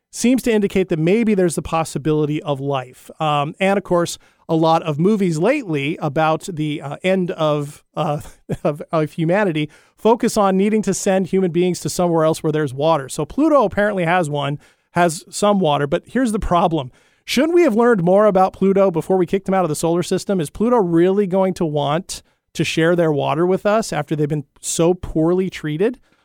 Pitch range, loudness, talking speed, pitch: 155-195 Hz, -18 LUFS, 200 wpm, 175 Hz